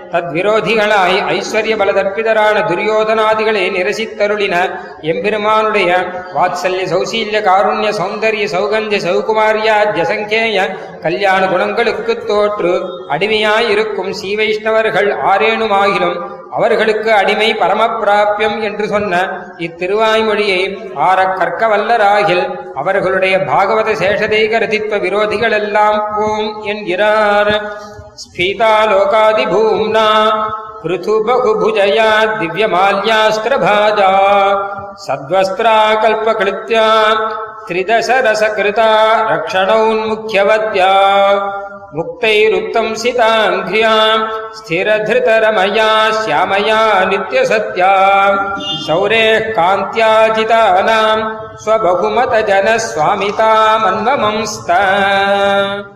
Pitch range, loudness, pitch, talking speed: 195-220 Hz, -12 LUFS, 215 Hz, 45 wpm